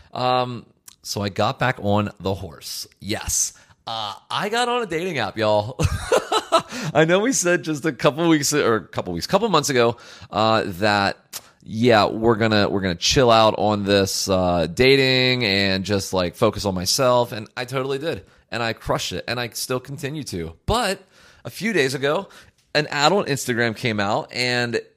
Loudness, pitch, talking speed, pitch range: -21 LUFS, 120 Hz, 190 wpm, 100-140 Hz